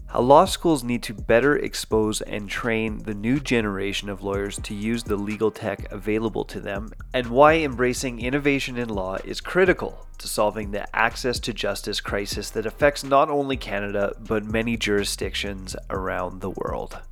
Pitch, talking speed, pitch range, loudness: 110 Hz, 170 wpm, 100-125 Hz, -24 LUFS